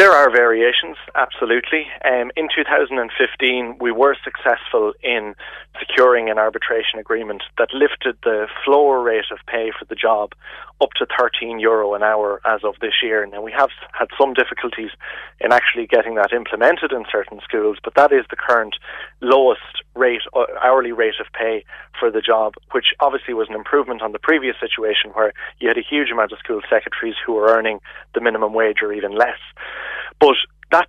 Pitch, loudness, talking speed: 140 Hz, -18 LUFS, 180 wpm